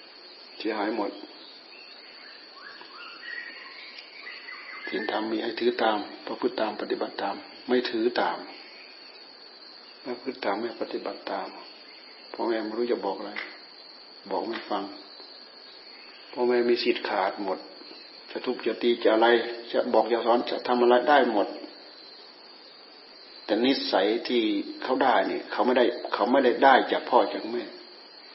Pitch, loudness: 310 Hz, -26 LUFS